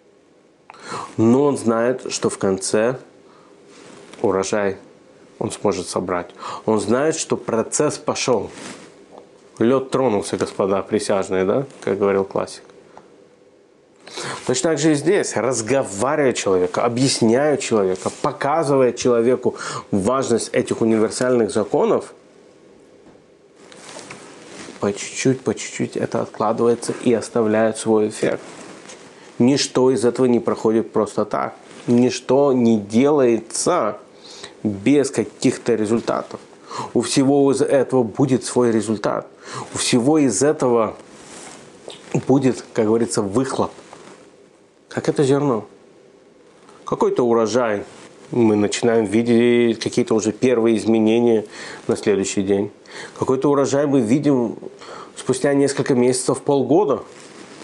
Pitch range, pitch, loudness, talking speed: 110-135 Hz, 120 Hz, -19 LUFS, 105 wpm